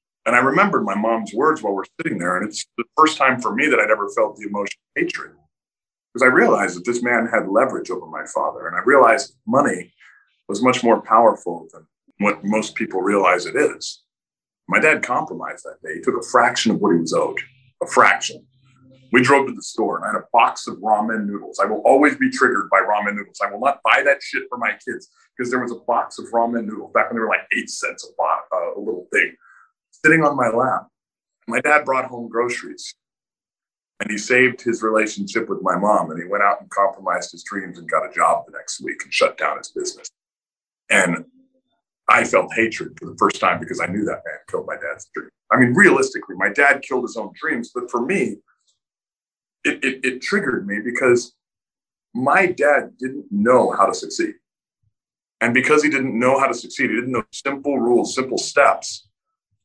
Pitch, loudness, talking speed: 130 Hz, -19 LUFS, 210 wpm